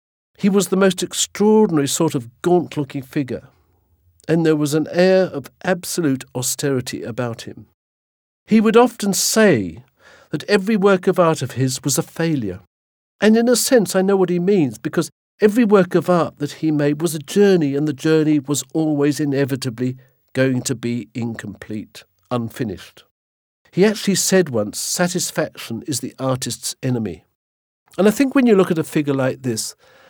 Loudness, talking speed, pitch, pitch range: -18 LUFS, 170 wpm, 145 Hz, 120-180 Hz